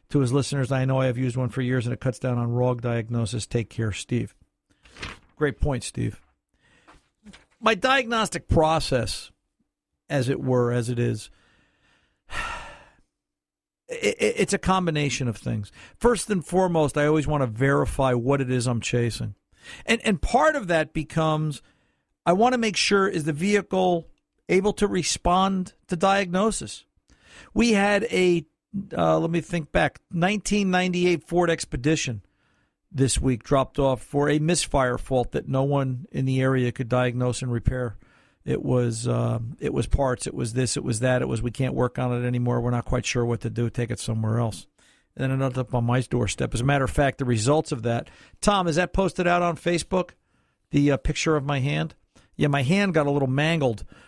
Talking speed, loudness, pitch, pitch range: 185 wpm, -24 LUFS, 140 Hz, 120-175 Hz